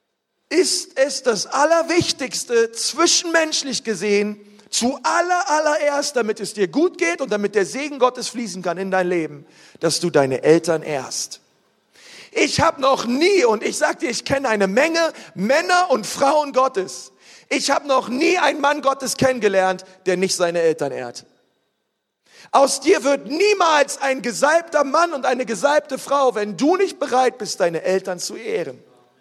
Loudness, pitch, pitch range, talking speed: -19 LUFS, 260 Hz, 200-300 Hz, 160 wpm